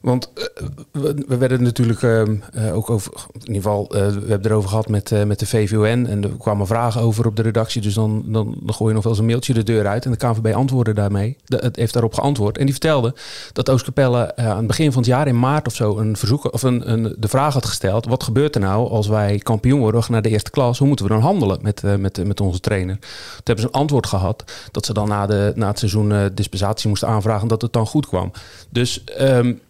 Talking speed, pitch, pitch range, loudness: 255 wpm, 115 Hz, 105-125 Hz, -19 LUFS